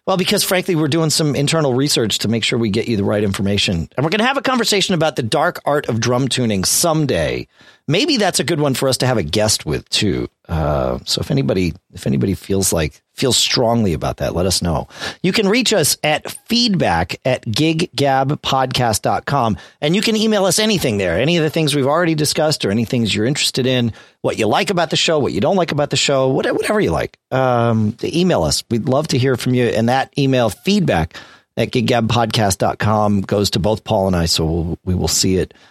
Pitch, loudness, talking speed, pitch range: 130 Hz, -16 LUFS, 220 wpm, 110-160 Hz